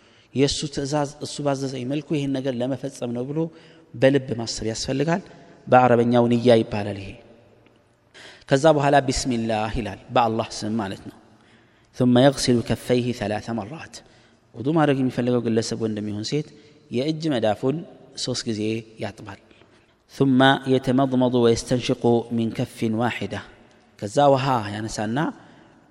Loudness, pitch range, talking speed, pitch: -22 LUFS, 115-135 Hz, 130 wpm, 120 Hz